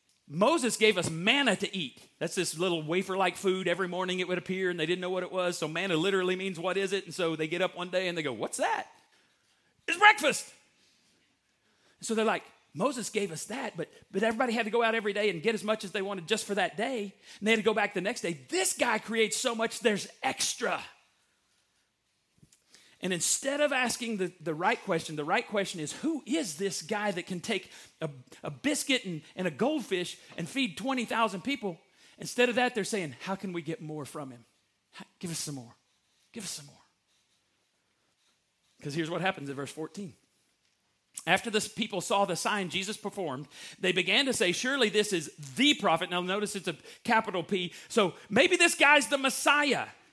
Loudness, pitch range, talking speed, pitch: -29 LUFS, 175-225 Hz, 205 wpm, 195 Hz